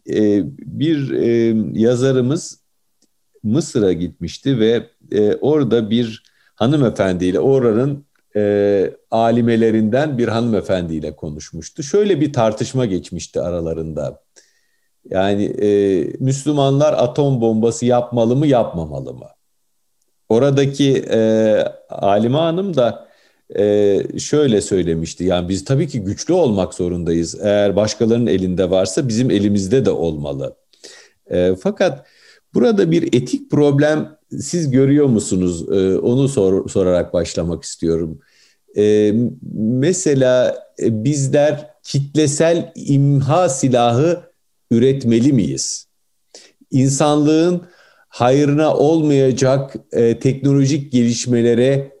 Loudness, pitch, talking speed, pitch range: -16 LUFS, 120 Hz, 90 wpm, 100-140 Hz